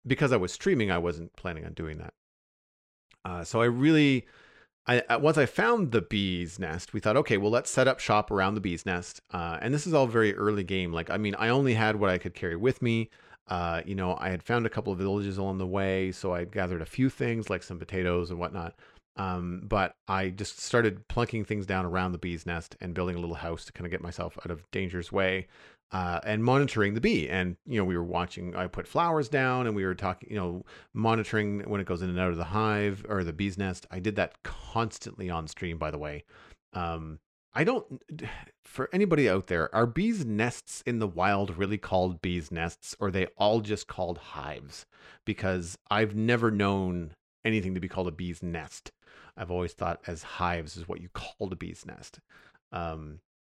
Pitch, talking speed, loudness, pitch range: 95 Hz, 220 wpm, -29 LUFS, 90-110 Hz